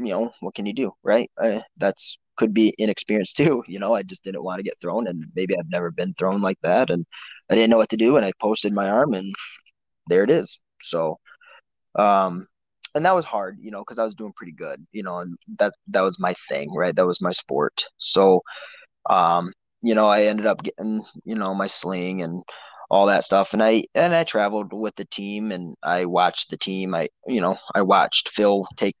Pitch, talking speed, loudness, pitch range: 100 Hz, 225 wpm, -22 LUFS, 95-110 Hz